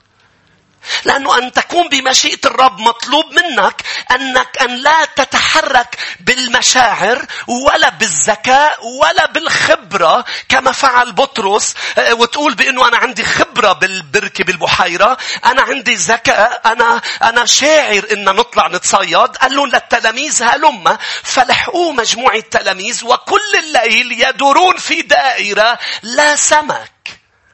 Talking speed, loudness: 105 wpm, -11 LUFS